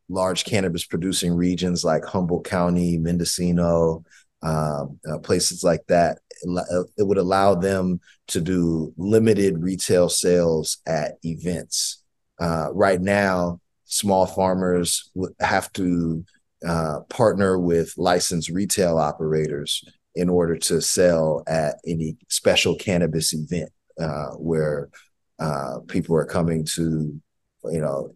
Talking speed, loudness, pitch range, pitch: 115 wpm, -22 LUFS, 80-90 Hz, 85 Hz